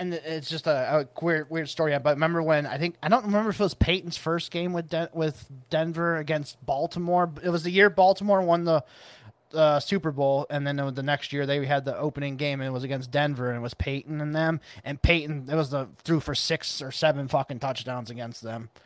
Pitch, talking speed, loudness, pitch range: 155 Hz, 235 wpm, -26 LUFS, 140-165 Hz